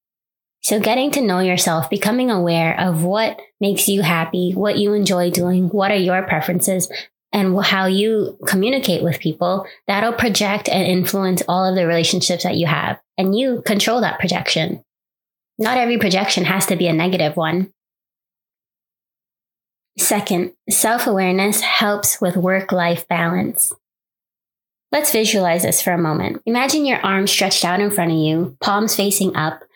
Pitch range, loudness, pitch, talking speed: 180-210 Hz, -17 LUFS, 190 Hz, 155 wpm